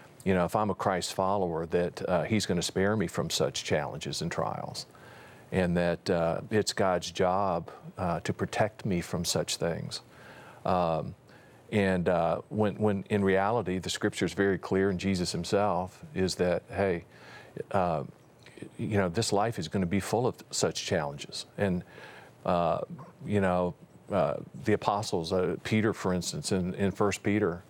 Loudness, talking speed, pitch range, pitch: -30 LUFS, 170 wpm, 90-105 Hz, 95 Hz